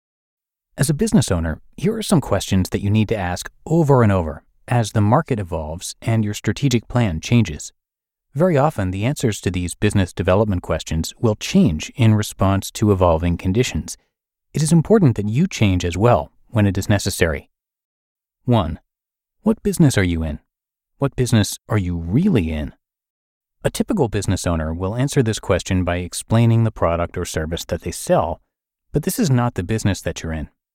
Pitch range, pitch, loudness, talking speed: 90-125 Hz, 105 Hz, -19 LUFS, 180 wpm